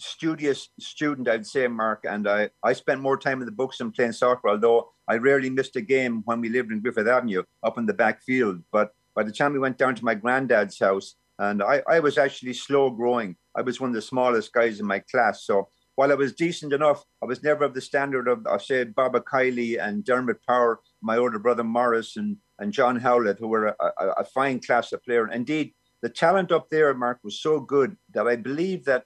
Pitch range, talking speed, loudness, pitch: 115-140 Hz, 230 wpm, -24 LUFS, 125 Hz